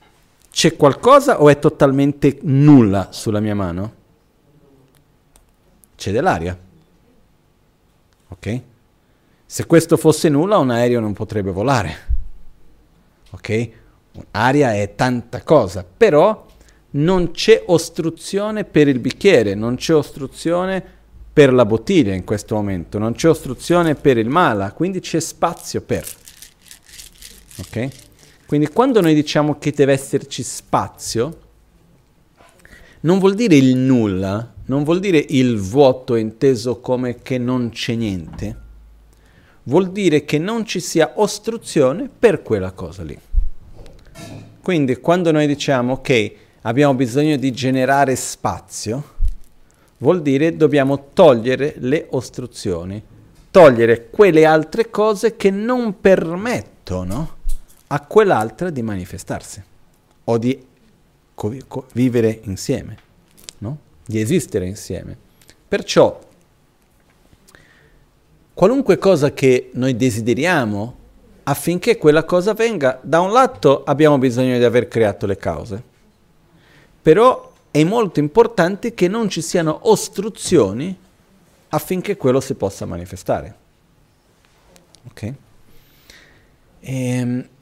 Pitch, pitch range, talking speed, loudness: 135 Hz, 110-160 Hz, 110 wpm, -17 LUFS